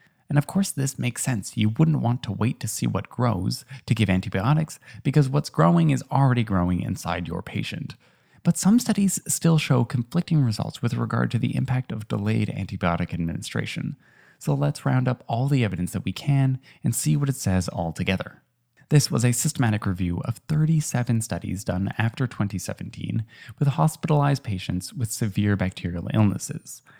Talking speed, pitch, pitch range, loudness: 175 wpm, 120 Hz, 100-145 Hz, -24 LUFS